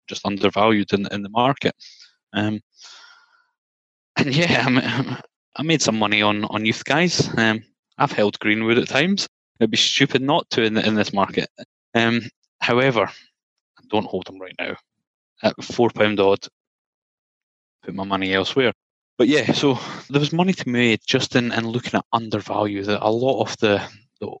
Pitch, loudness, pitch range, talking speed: 115 Hz, -20 LUFS, 105-135 Hz, 170 wpm